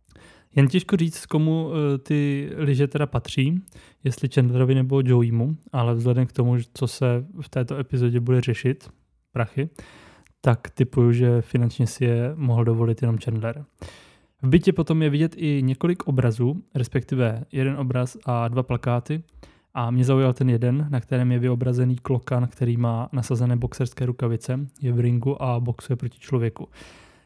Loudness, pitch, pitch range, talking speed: -23 LUFS, 125 Hz, 120-140 Hz, 155 wpm